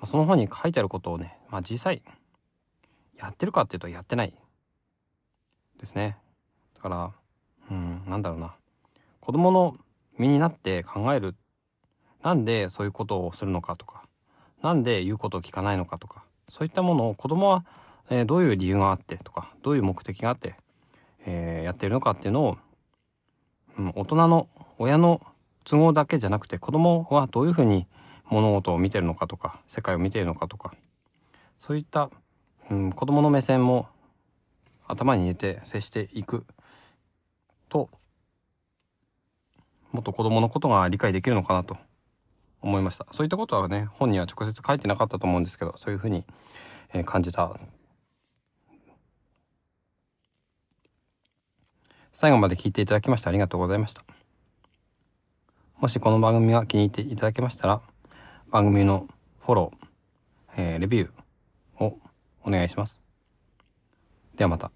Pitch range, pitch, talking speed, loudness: 95-125 Hz, 105 Hz, 315 characters per minute, -25 LUFS